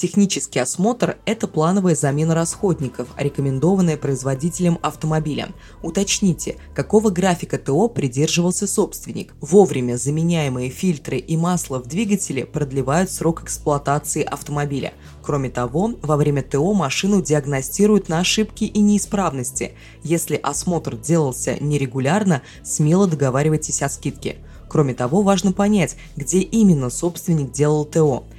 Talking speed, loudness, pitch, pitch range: 115 wpm, -20 LUFS, 155 Hz, 140-185 Hz